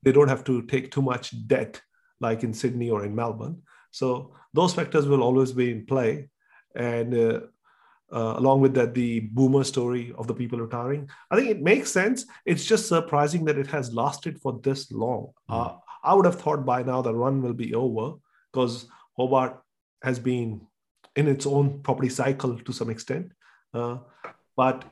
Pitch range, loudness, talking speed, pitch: 120-140 Hz, -25 LUFS, 185 wpm, 130 Hz